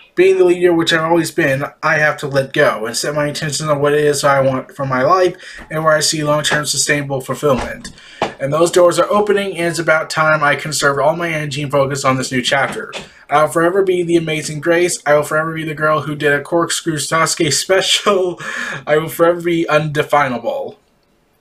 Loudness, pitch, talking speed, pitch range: -15 LUFS, 155 Hz, 210 wpm, 145-170 Hz